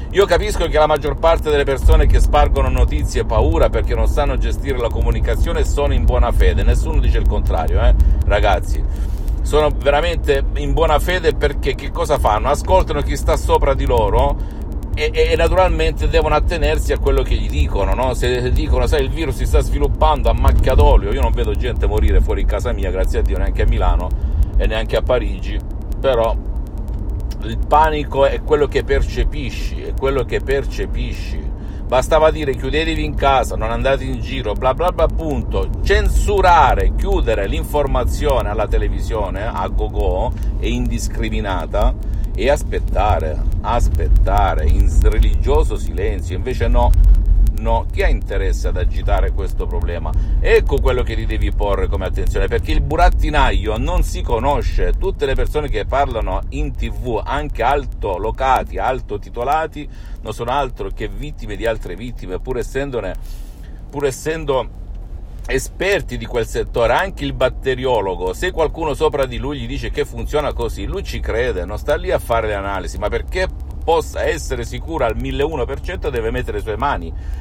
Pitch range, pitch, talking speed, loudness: 85-145 Hz, 110 Hz, 165 wpm, -18 LUFS